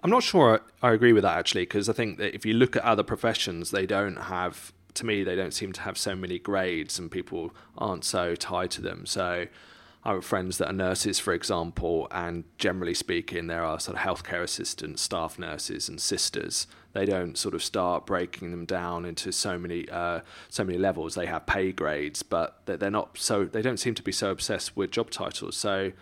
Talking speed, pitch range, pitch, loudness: 215 wpm, 85-100 Hz, 90 Hz, -28 LUFS